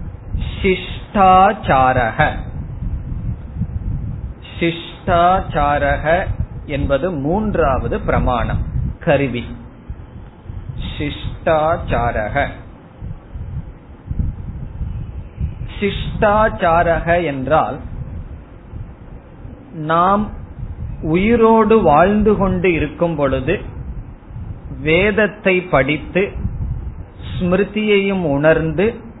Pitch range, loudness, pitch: 120-190 Hz, -17 LUFS, 160 Hz